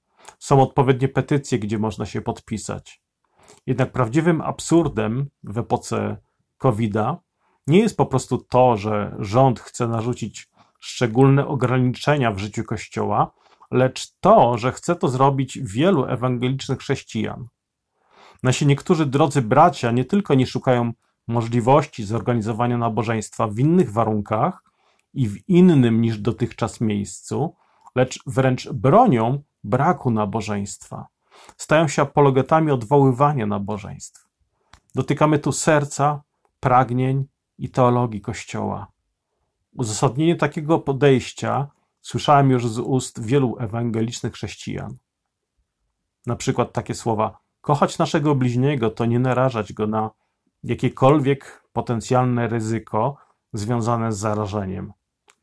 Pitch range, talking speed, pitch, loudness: 115-140 Hz, 110 wpm, 125 Hz, -21 LUFS